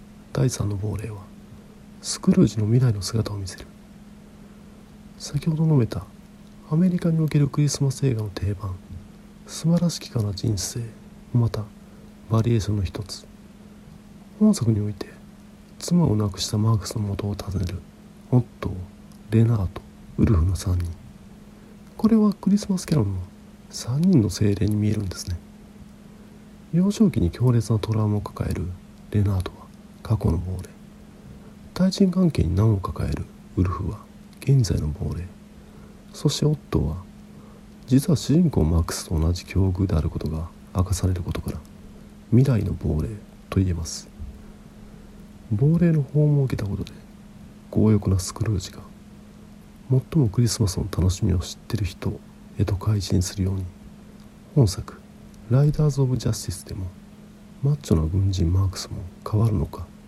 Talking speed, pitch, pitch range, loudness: 295 characters per minute, 110 Hz, 95-155 Hz, -23 LUFS